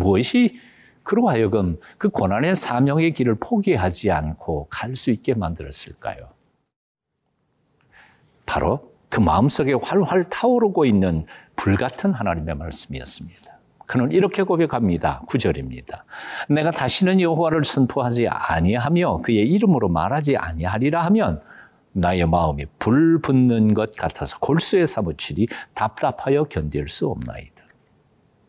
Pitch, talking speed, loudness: 125 Hz, 295 characters per minute, -20 LUFS